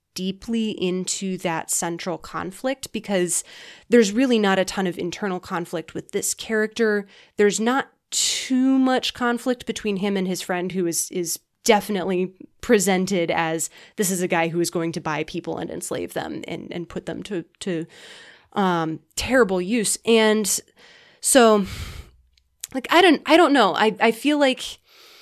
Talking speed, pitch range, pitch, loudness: 160 wpm, 175-230 Hz, 195 Hz, -22 LUFS